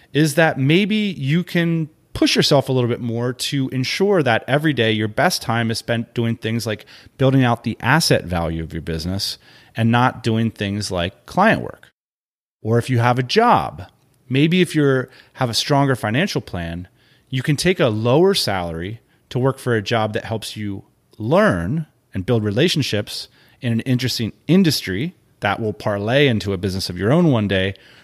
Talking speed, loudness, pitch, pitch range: 185 wpm, -19 LUFS, 120 Hz, 110-145 Hz